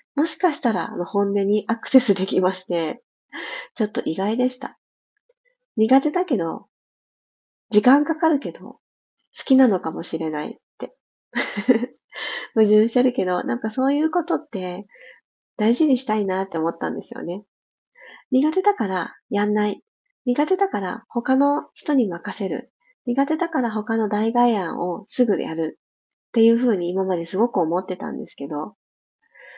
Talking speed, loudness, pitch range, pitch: 290 characters per minute, -22 LUFS, 195-275 Hz, 230 Hz